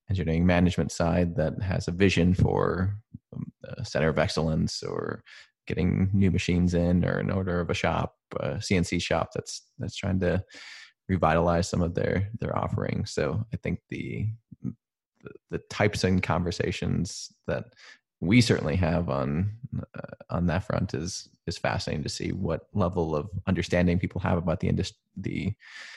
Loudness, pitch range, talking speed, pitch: -27 LUFS, 85-105 Hz, 160 wpm, 90 Hz